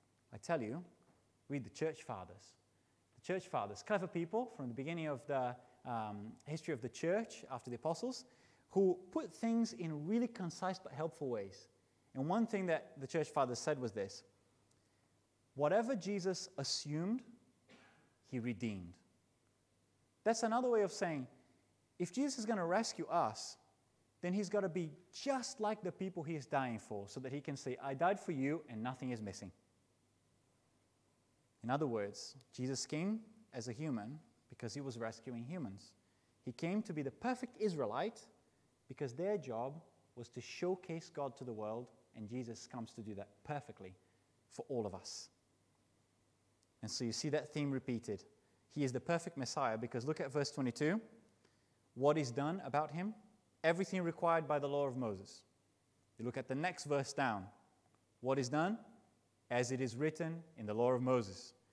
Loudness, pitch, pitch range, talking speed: -41 LUFS, 135 Hz, 115-170 Hz, 170 wpm